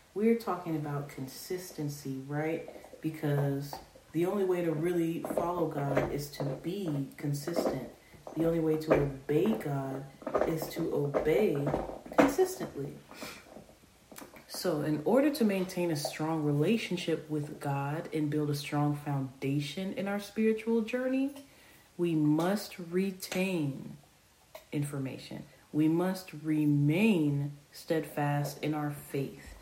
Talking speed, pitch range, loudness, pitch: 115 wpm, 145-180 Hz, -32 LUFS, 155 Hz